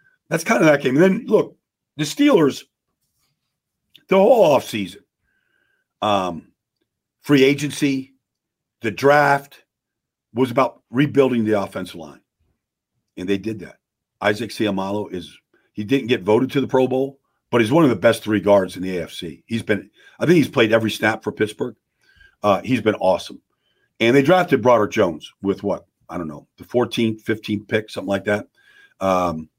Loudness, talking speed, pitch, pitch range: -19 LUFS, 165 wpm, 120 Hz, 105-140 Hz